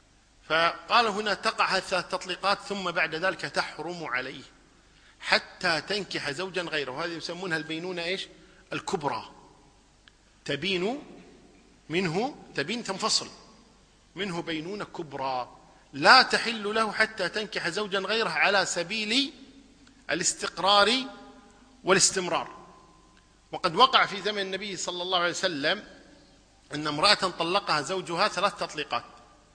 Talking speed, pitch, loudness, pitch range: 110 wpm, 185 Hz, -26 LUFS, 165-205 Hz